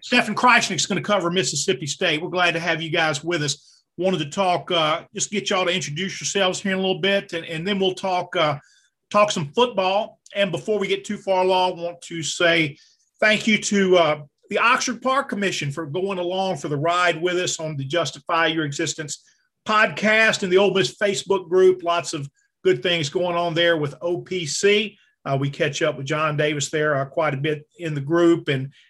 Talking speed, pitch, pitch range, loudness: 215 wpm, 175 Hz, 160-195 Hz, -21 LUFS